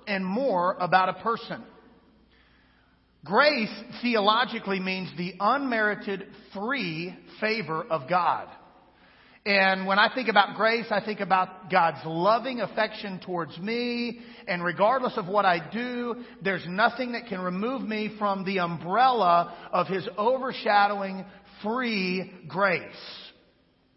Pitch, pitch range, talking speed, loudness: 205 Hz, 185-230 Hz, 120 wpm, -26 LUFS